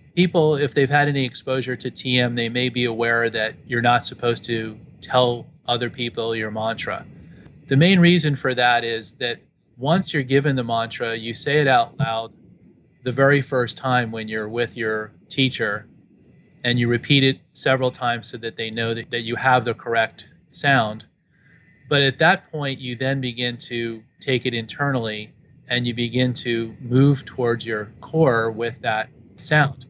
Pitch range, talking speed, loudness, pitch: 115-140 Hz, 175 wpm, -21 LUFS, 125 Hz